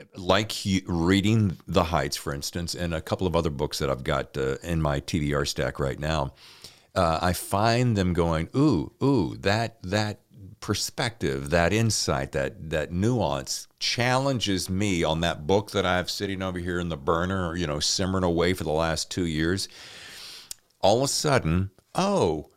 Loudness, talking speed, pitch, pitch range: -26 LUFS, 175 wpm, 90 Hz, 80-100 Hz